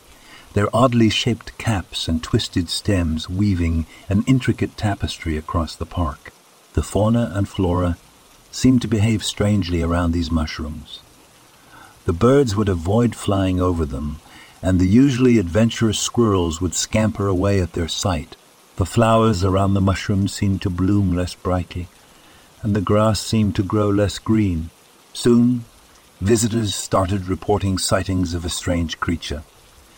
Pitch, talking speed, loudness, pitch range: 100 Hz, 140 wpm, -20 LUFS, 85-110 Hz